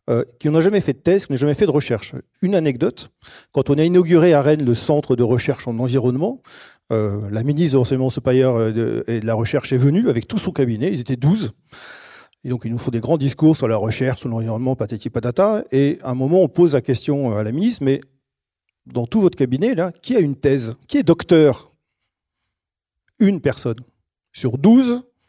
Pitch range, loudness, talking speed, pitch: 120-165 Hz, -18 LUFS, 215 wpm, 135 Hz